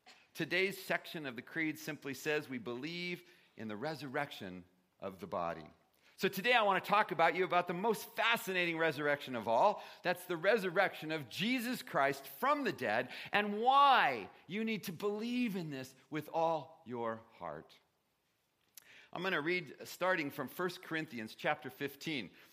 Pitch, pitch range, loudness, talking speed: 165 Hz, 135-190 Hz, -35 LUFS, 165 wpm